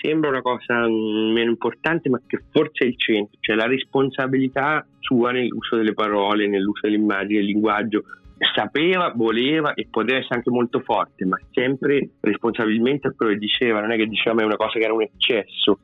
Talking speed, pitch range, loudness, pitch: 180 wpm, 110-130 Hz, -21 LUFS, 115 Hz